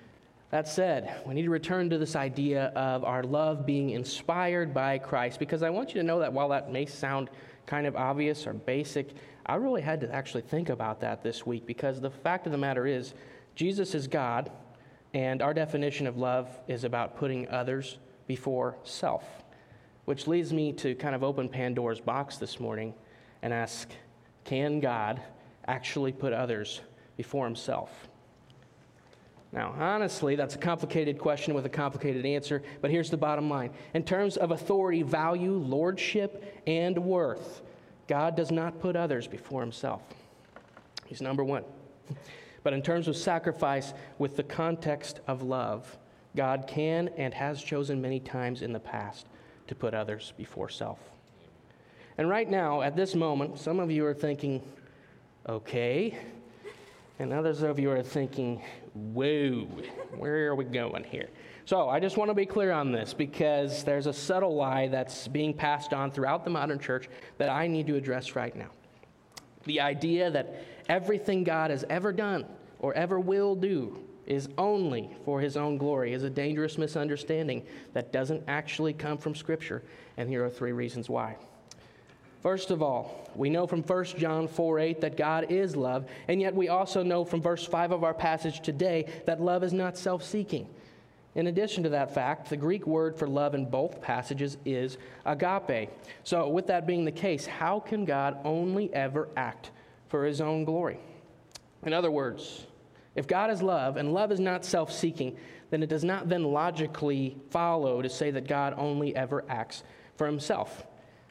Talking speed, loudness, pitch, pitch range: 175 wpm, -31 LUFS, 145 Hz, 130-165 Hz